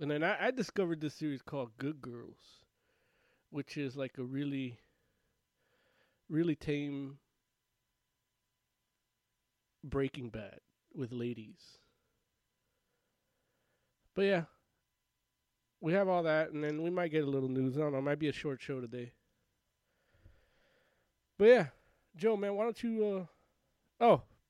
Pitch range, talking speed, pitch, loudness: 130-170 Hz, 125 wpm, 145 Hz, -34 LUFS